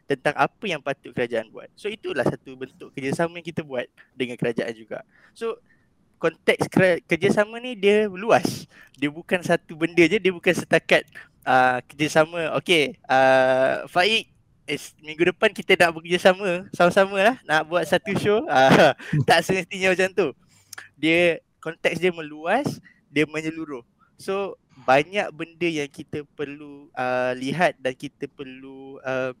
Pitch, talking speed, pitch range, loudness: 165 Hz, 150 wpm, 140-185 Hz, -22 LUFS